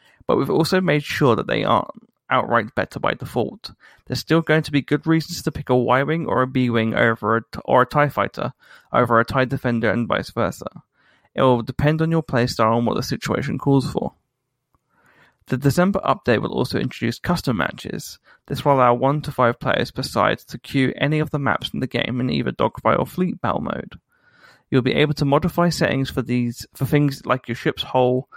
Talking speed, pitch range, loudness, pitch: 205 wpm, 125-150 Hz, -20 LUFS, 135 Hz